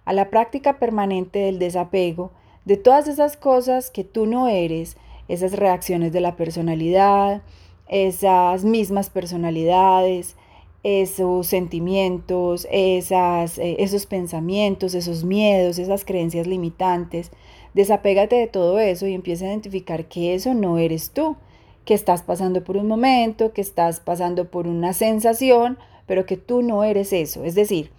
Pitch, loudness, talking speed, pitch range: 185 Hz, -20 LUFS, 140 wpm, 175-205 Hz